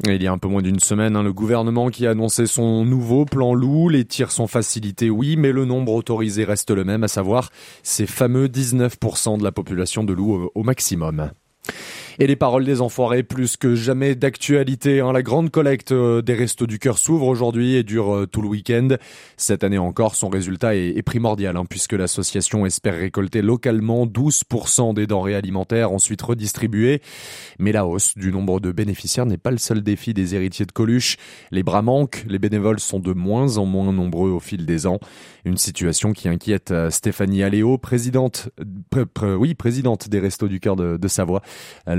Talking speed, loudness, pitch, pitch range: 185 wpm, -19 LUFS, 110 Hz, 100-125 Hz